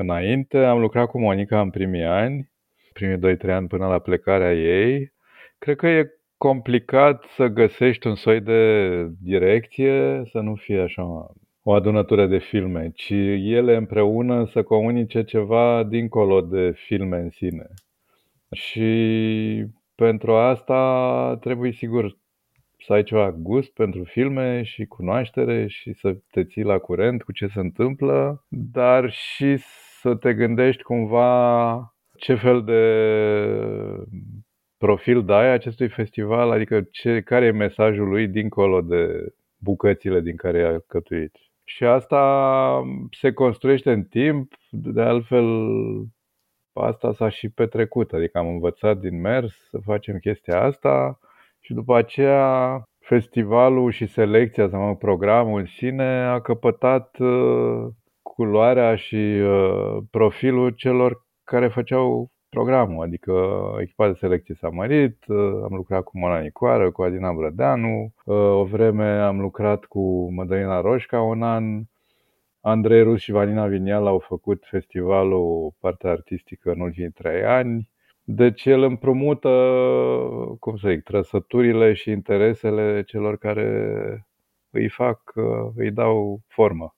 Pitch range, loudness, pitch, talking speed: 95-125 Hz, -21 LUFS, 110 Hz, 130 wpm